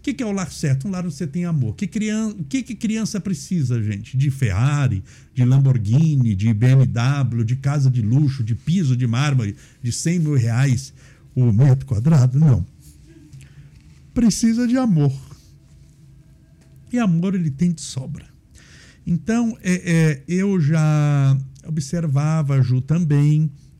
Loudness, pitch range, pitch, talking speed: -19 LUFS, 130-175 Hz, 140 Hz, 150 wpm